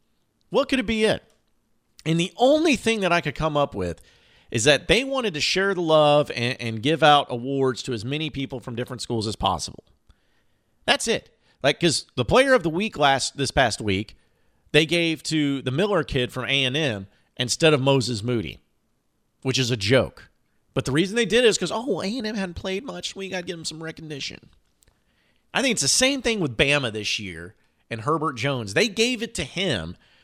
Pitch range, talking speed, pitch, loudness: 120-180 Hz, 205 wpm, 145 Hz, -22 LUFS